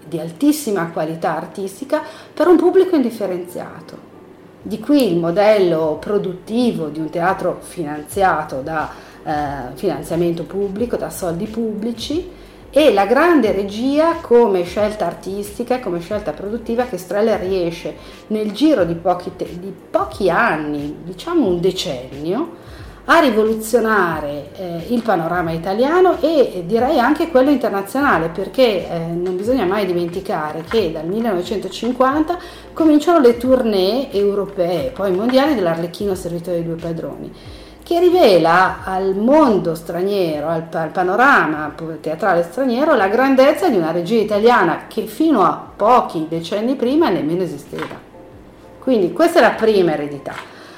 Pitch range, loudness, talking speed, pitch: 170-255 Hz, -17 LUFS, 130 wpm, 200 Hz